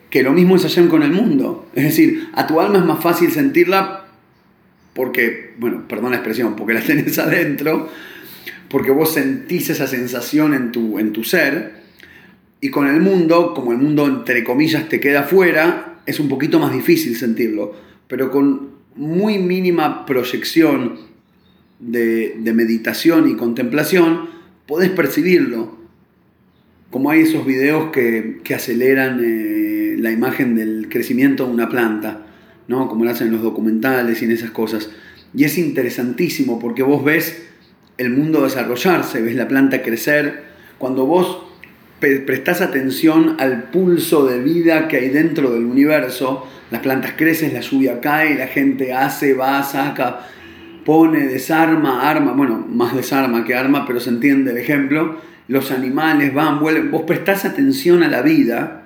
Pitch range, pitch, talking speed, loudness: 125-170 Hz, 140 Hz, 155 wpm, -16 LUFS